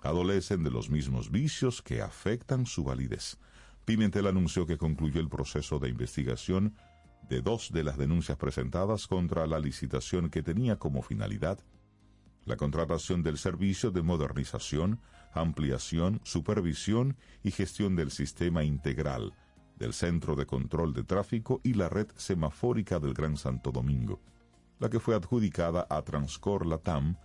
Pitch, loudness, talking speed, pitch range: 85 Hz, -32 LUFS, 140 wpm, 75-105 Hz